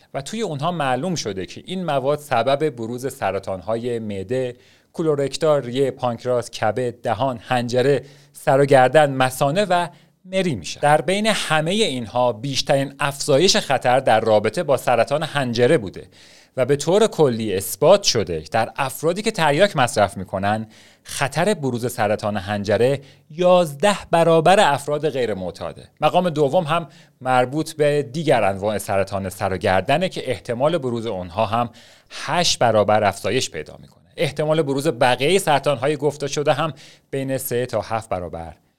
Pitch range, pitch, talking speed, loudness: 115-155 Hz, 135 Hz, 140 wpm, -20 LUFS